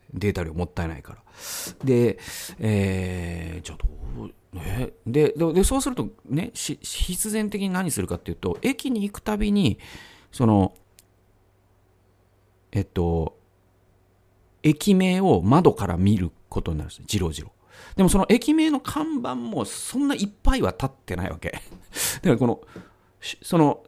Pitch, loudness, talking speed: 95 Hz, -24 LUFS, 275 characters per minute